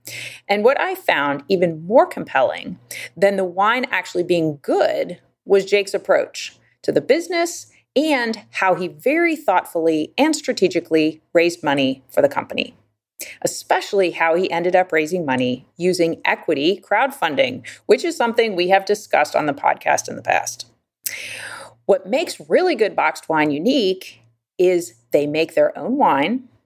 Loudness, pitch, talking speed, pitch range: -19 LUFS, 185 Hz, 150 wpm, 155-245 Hz